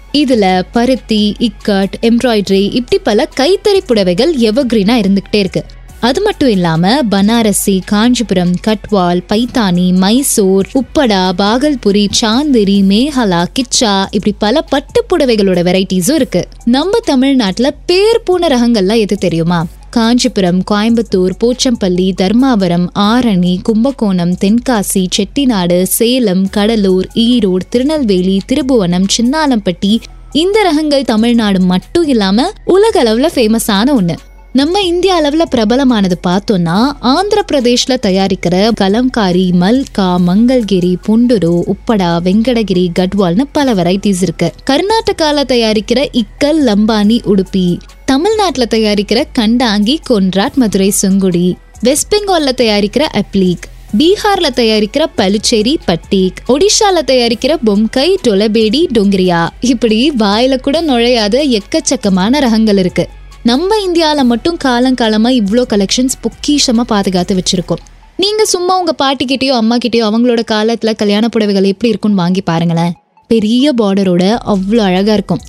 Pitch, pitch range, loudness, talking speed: 225 Hz, 195-260 Hz, -11 LUFS, 110 wpm